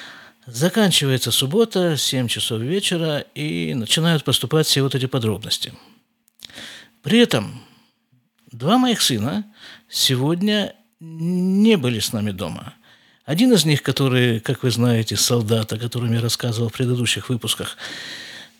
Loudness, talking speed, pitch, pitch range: -19 LUFS, 125 wpm, 135 Hz, 120-175 Hz